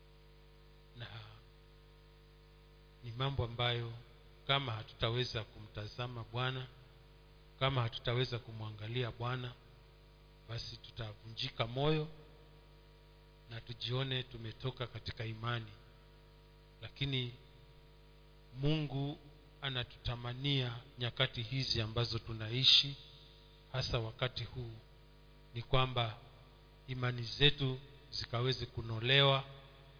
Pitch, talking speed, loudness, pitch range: 130 Hz, 70 wpm, -36 LUFS, 120-150 Hz